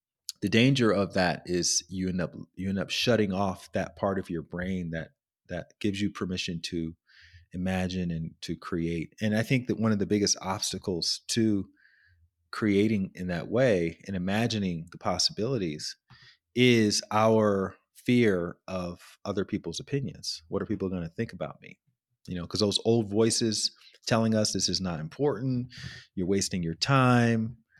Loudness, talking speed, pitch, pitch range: -28 LUFS, 165 wpm, 100 Hz, 90-115 Hz